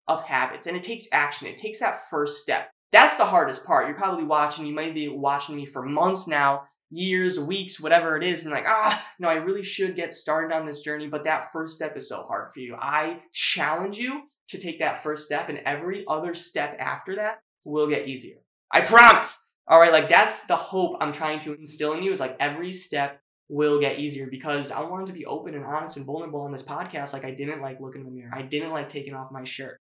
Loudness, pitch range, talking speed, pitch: -24 LUFS, 145-180 Hz, 235 wpm, 155 Hz